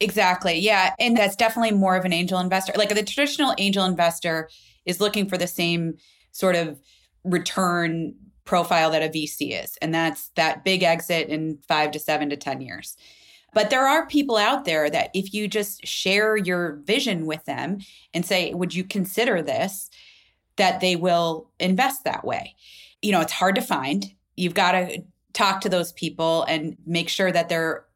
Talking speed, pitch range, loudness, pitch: 180 wpm, 165-205 Hz, -22 LUFS, 180 Hz